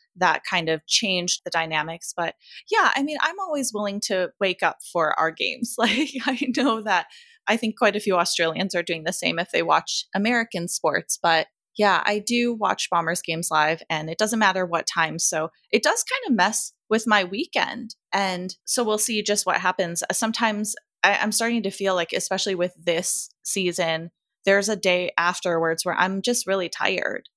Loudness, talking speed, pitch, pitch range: -23 LUFS, 195 wpm, 195 Hz, 175-230 Hz